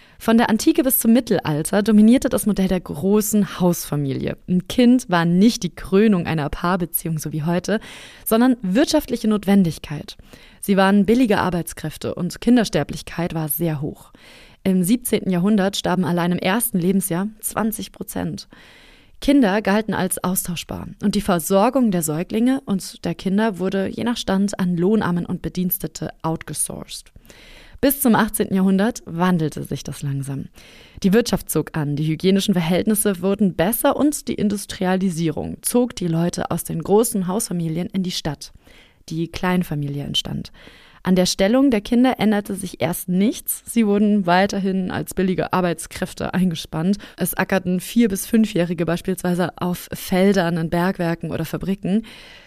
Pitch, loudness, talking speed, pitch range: 190 Hz, -20 LUFS, 145 wpm, 170-215 Hz